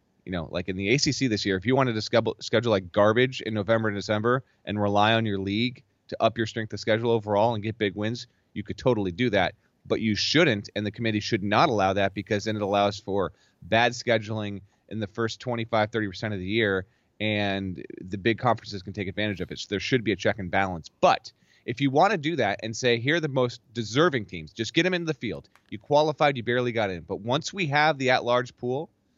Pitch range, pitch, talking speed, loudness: 100-125 Hz, 110 Hz, 245 wpm, -26 LUFS